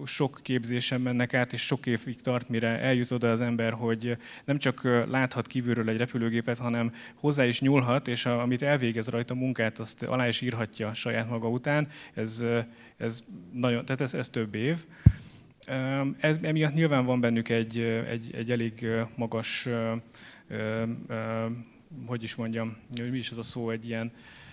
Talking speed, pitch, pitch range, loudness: 160 wpm, 120 Hz, 115-130 Hz, -29 LUFS